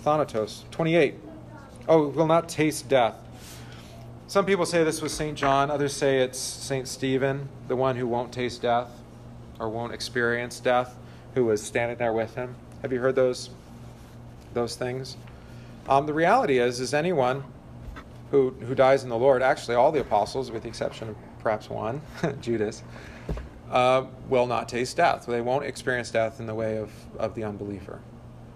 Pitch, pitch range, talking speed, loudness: 125 Hz, 115-135 Hz, 170 wpm, -26 LUFS